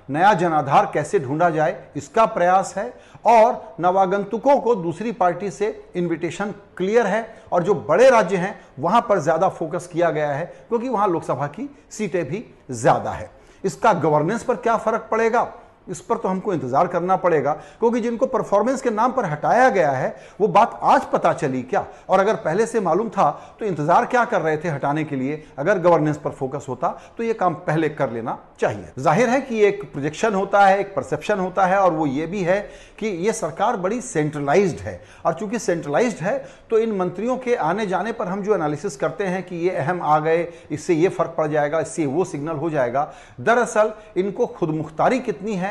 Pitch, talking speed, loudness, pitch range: 190 Hz, 195 wpm, -21 LUFS, 160-220 Hz